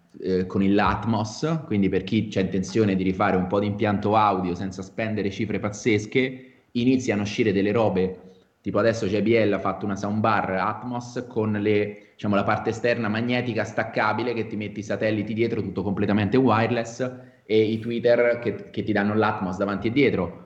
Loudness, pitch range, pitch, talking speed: -24 LUFS, 100-115 Hz, 105 Hz, 175 wpm